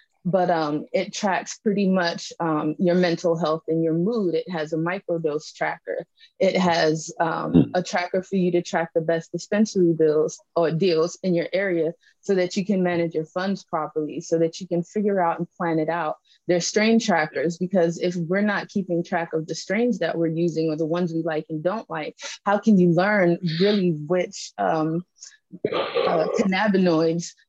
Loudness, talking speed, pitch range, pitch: -23 LUFS, 190 wpm, 165-190 Hz, 175 Hz